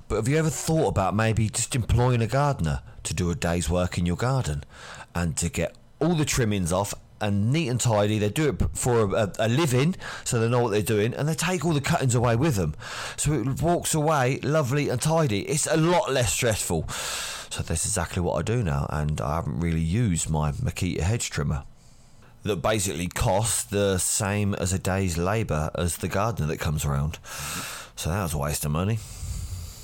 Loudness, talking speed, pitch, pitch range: -25 LUFS, 205 wpm, 105 Hz, 85-130 Hz